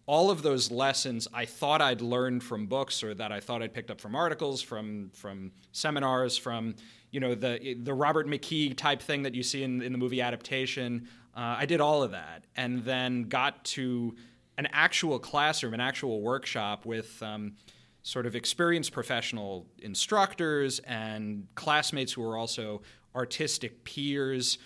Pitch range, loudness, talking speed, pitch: 115-135 Hz, -30 LUFS, 170 wpm, 125 Hz